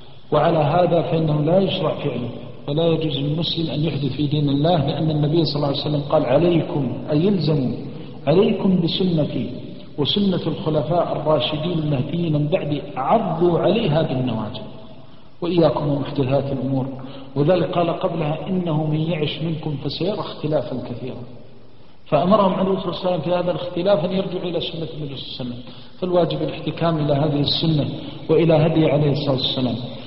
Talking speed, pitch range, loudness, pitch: 150 wpm, 140-170 Hz, -20 LUFS, 155 Hz